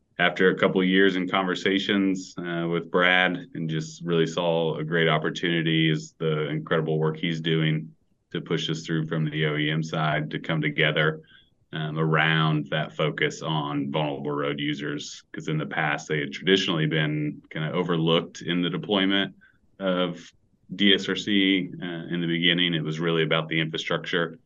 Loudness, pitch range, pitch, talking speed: -25 LUFS, 80-90 Hz, 80 Hz, 165 wpm